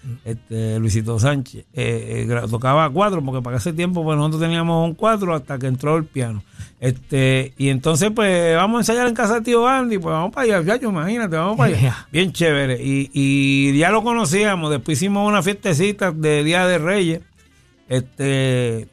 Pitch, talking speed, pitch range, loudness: 155 Hz, 180 wpm, 130-190 Hz, -19 LUFS